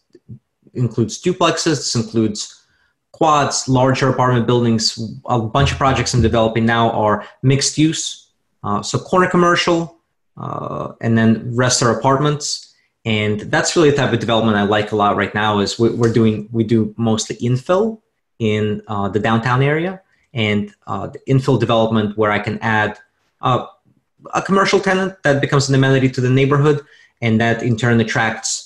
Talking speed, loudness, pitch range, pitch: 160 wpm, -17 LUFS, 110-140 Hz, 120 Hz